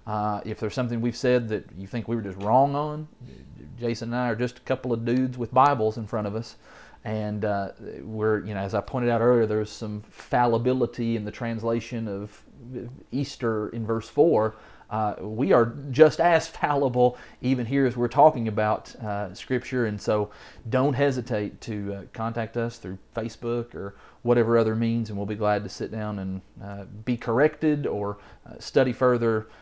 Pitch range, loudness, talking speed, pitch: 105-125 Hz, -26 LUFS, 190 wpm, 115 Hz